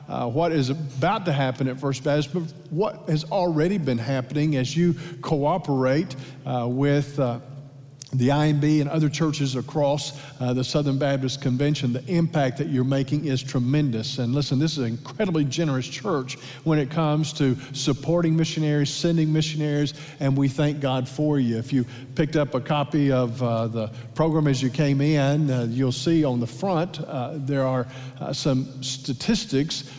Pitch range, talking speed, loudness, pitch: 130-155 Hz, 175 wpm, -24 LUFS, 140 Hz